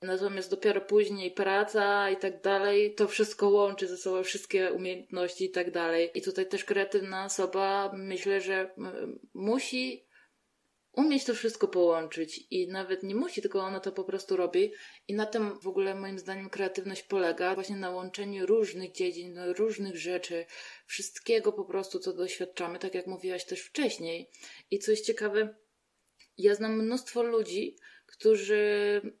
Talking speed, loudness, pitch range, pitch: 150 wpm, -31 LUFS, 185-220 Hz, 195 Hz